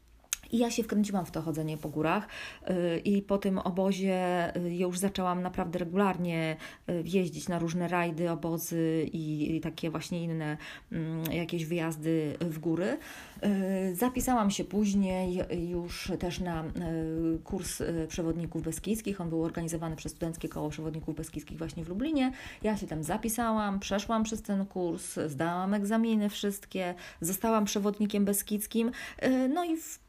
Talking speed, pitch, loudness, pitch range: 135 wpm, 180 Hz, -32 LUFS, 165-205 Hz